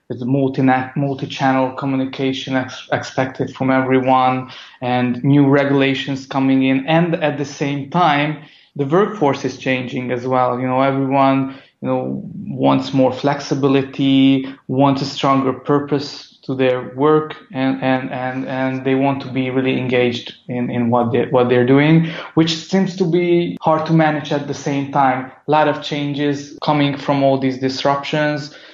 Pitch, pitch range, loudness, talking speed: 135 Hz, 130-145 Hz, -17 LUFS, 160 wpm